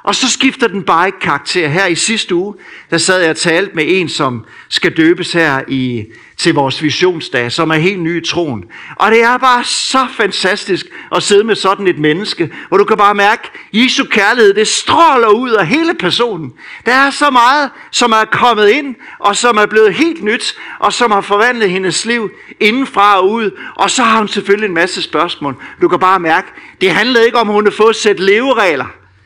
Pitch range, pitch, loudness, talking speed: 170-225 Hz, 200 Hz, -11 LUFS, 215 wpm